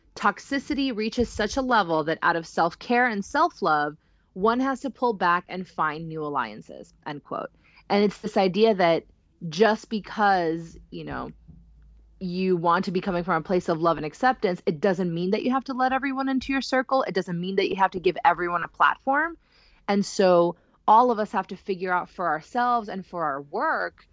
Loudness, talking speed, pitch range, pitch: -25 LUFS, 200 wpm, 175-240 Hz, 195 Hz